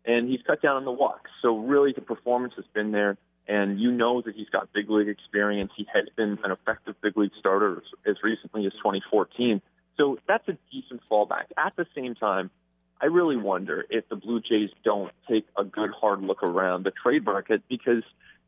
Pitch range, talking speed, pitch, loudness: 105-125 Hz, 200 wpm, 110 Hz, -26 LUFS